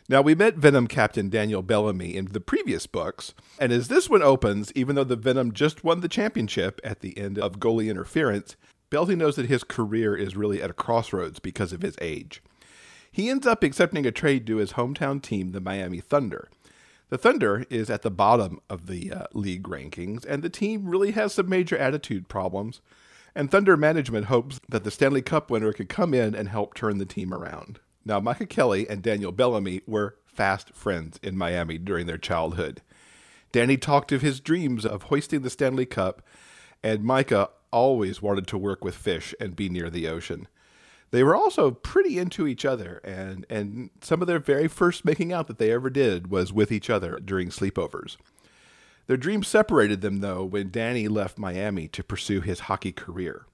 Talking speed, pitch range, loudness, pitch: 195 wpm, 100-140 Hz, -25 LUFS, 110 Hz